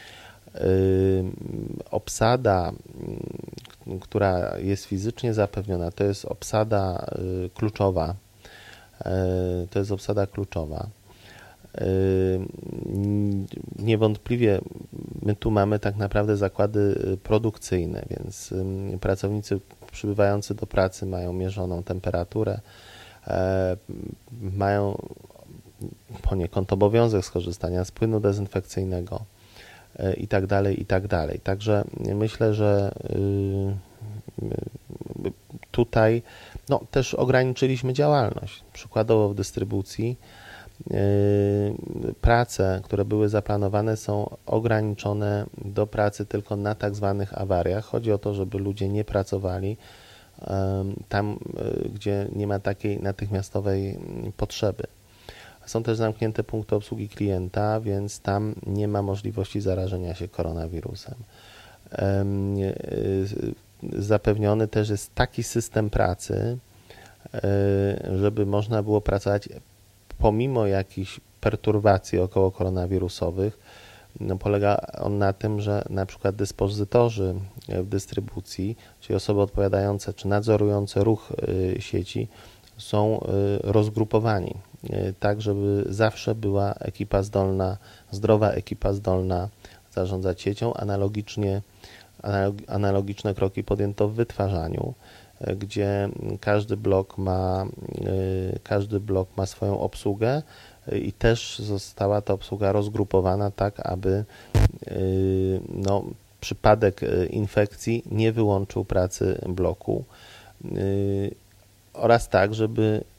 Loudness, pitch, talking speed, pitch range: -25 LUFS, 100 Hz, 90 wpm, 95-110 Hz